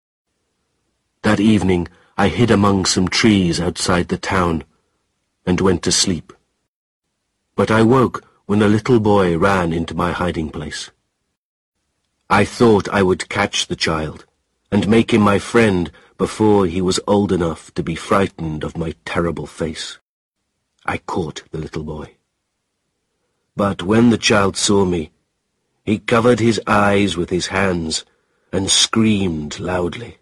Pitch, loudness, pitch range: 95 Hz, -17 LUFS, 85-105 Hz